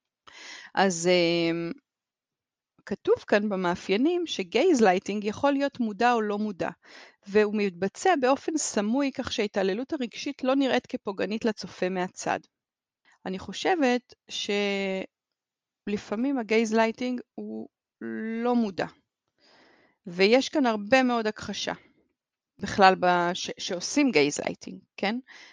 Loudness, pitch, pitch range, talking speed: -26 LUFS, 215 Hz, 190-255 Hz, 100 wpm